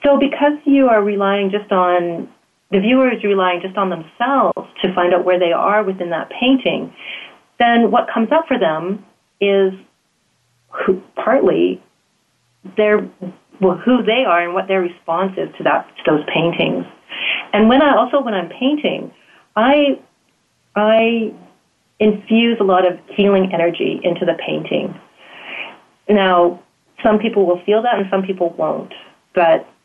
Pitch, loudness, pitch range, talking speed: 200 Hz, -16 LUFS, 180-230 Hz, 155 wpm